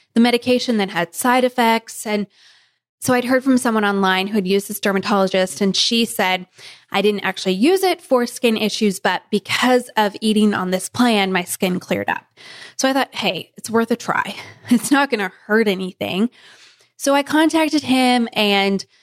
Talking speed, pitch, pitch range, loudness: 185 wpm, 215 Hz, 195-250 Hz, -18 LUFS